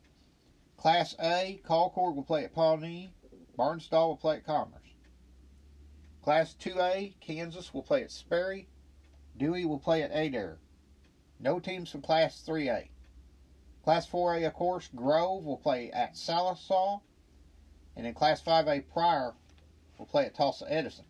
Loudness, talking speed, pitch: -31 LUFS, 135 wpm, 155 Hz